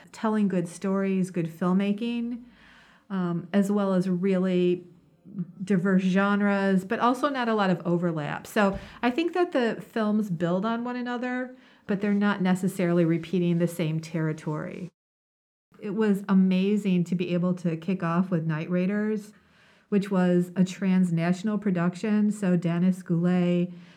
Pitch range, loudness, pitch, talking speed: 175-210 Hz, -26 LUFS, 190 Hz, 145 wpm